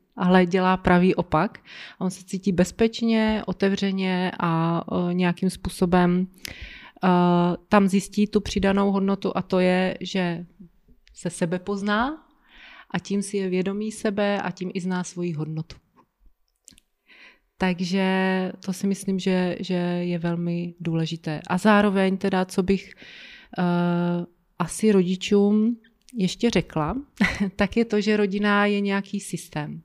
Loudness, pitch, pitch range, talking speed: -23 LUFS, 190 Hz, 180-205 Hz, 125 wpm